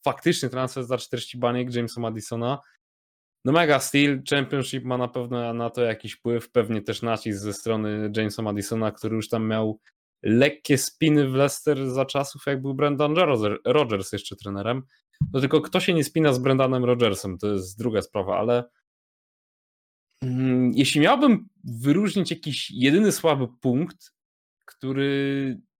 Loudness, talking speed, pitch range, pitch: -24 LUFS, 150 wpm, 115-140 Hz, 125 Hz